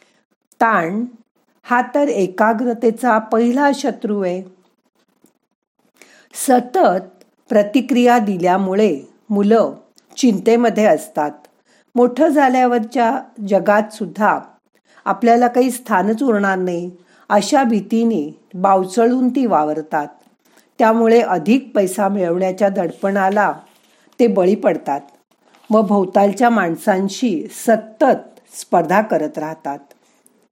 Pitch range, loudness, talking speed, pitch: 195-245 Hz, -16 LUFS, 85 wpm, 220 Hz